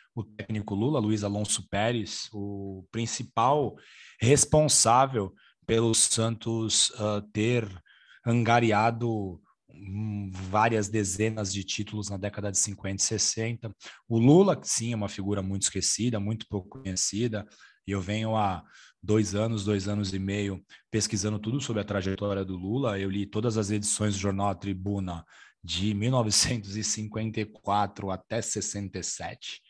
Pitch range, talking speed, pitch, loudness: 100-115 Hz, 130 wpm, 105 Hz, -27 LUFS